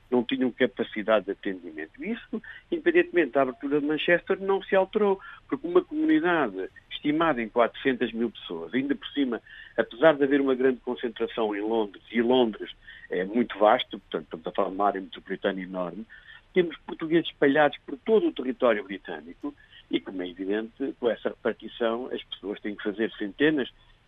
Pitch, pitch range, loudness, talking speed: 130 Hz, 110-185 Hz, -27 LUFS, 170 wpm